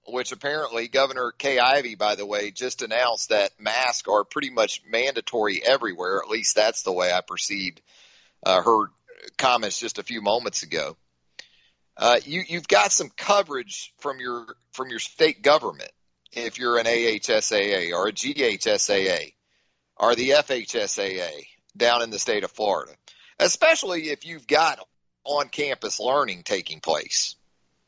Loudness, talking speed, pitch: -23 LUFS, 150 wpm, 140 Hz